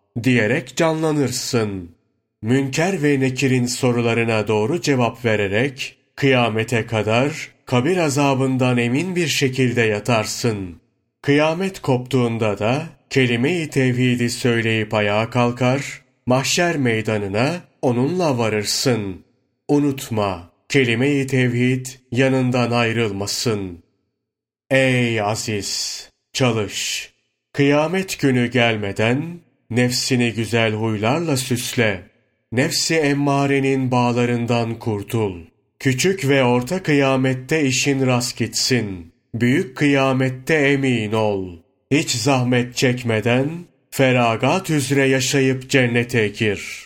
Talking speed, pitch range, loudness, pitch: 85 wpm, 115-135 Hz, -19 LUFS, 125 Hz